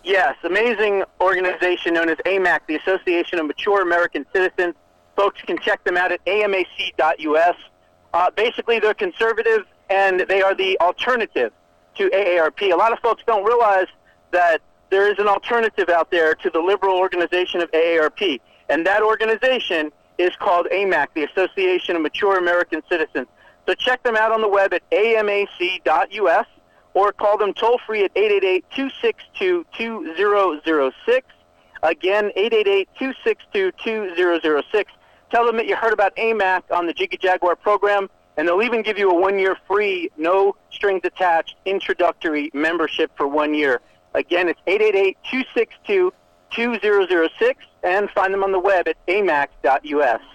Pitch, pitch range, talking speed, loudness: 195 Hz, 175-230 Hz, 140 wpm, -19 LUFS